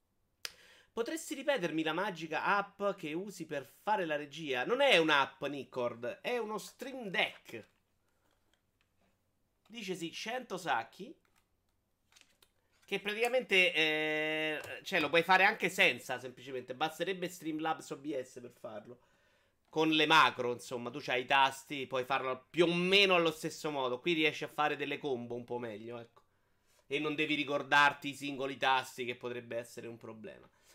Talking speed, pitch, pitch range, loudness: 150 wpm, 145 Hz, 120-170 Hz, -33 LUFS